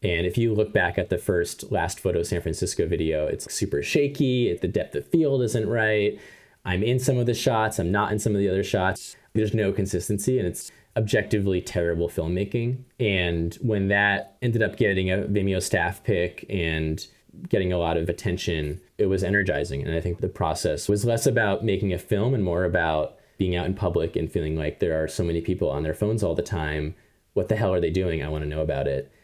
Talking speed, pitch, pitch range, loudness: 220 wpm, 95 Hz, 85-110 Hz, -25 LUFS